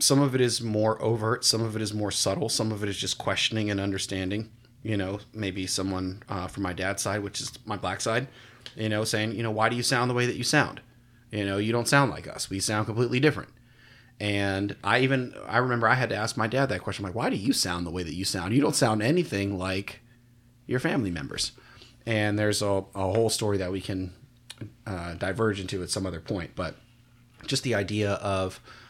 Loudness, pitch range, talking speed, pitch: -27 LUFS, 100-120 Hz, 235 wpm, 110 Hz